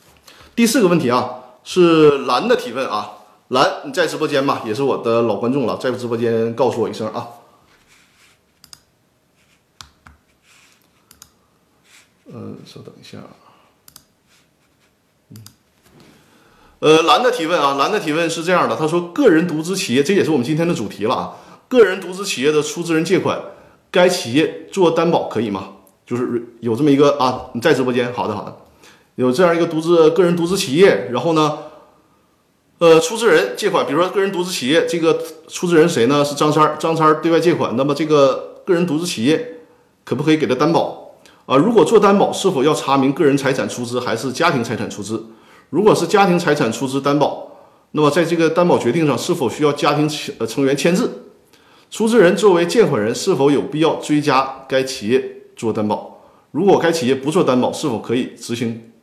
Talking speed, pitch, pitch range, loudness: 280 characters per minute, 155 Hz, 130-175 Hz, -16 LUFS